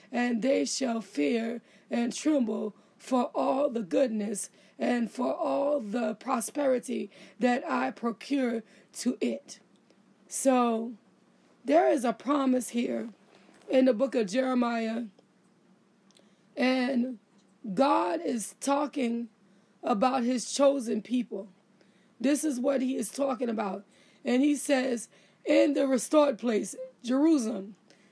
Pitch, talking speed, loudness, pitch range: 240 Hz, 115 wpm, -29 LUFS, 210-265 Hz